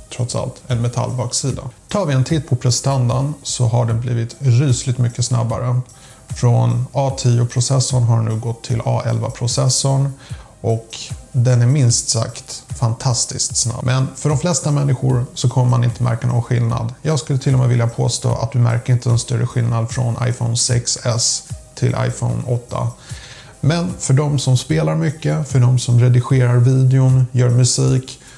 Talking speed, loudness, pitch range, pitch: 165 wpm, -17 LUFS, 120-130 Hz, 125 Hz